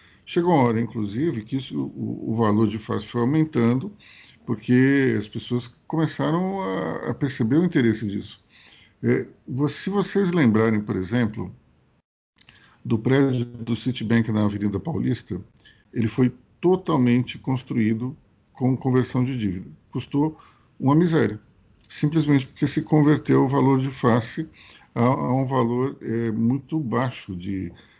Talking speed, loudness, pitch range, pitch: 135 wpm, -23 LUFS, 110-140 Hz, 125 Hz